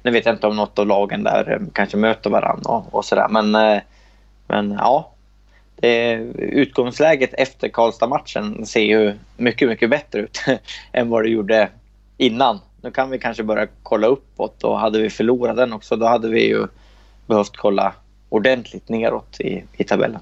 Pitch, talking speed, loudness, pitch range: 110 Hz, 165 wpm, -19 LUFS, 105-115 Hz